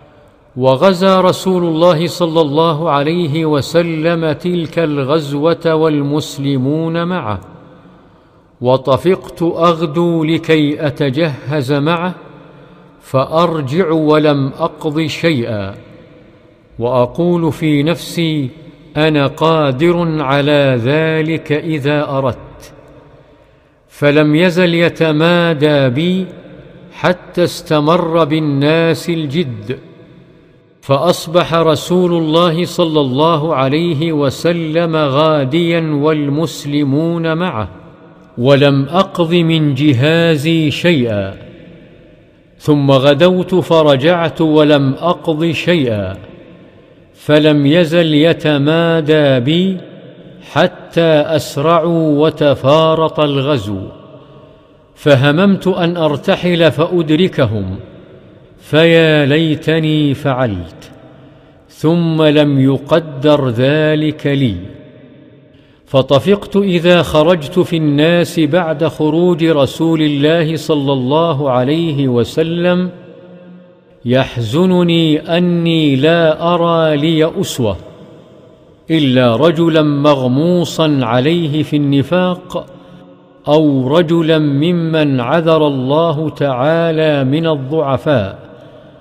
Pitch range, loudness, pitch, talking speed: 145-165 Hz, -13 LUFS, 155 Hz, 75 wpm